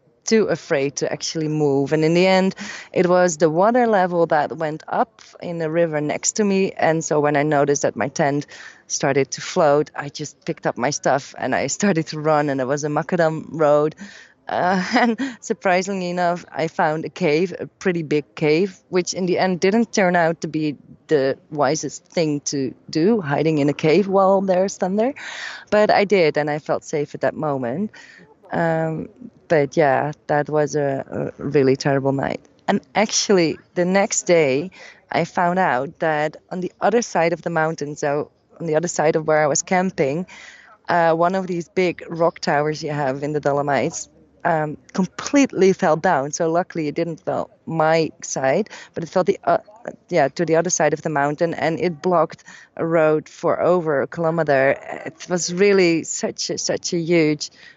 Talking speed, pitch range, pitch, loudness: 190 wpm, 150-180 Hz, 165 Hz, -20 LUFS